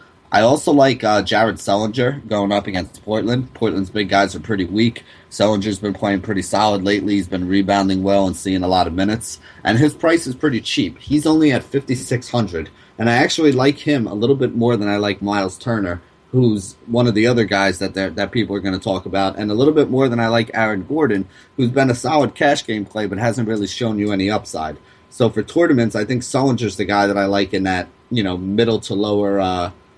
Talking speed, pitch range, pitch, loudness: 230 wpm, 100-120 Hz, 105 Hz, -18 LUFS